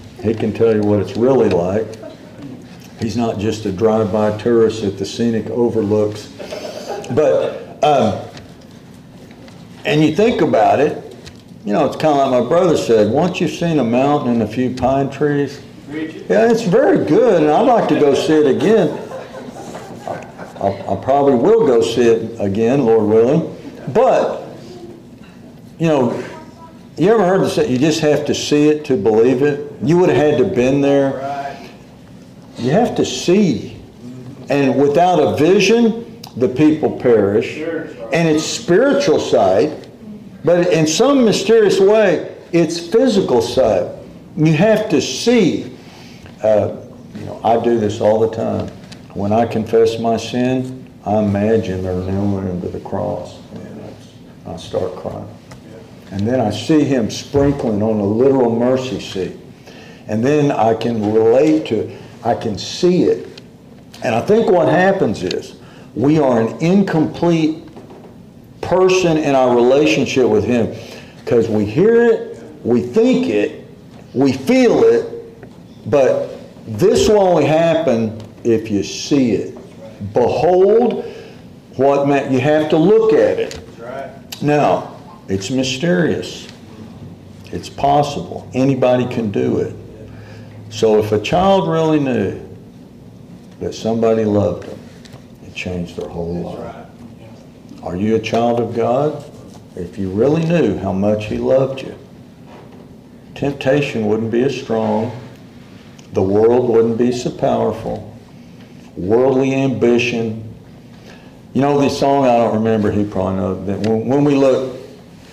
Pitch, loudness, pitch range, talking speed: 125 Hz, -15 LUFS, 110-155 Hz, 145 wpm